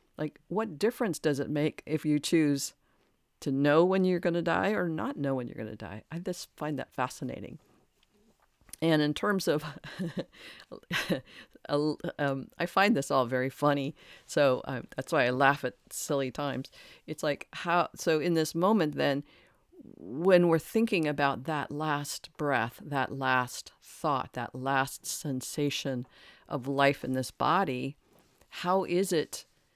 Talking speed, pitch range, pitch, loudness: 160 wpm, 135-170 Hz, 150 Hz, -30 LUFS